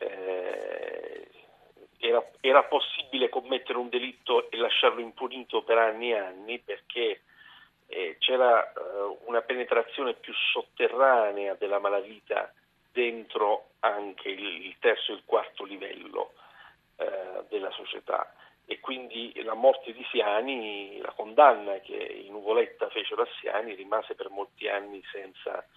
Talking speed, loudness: 125 wpm, -28 LUFS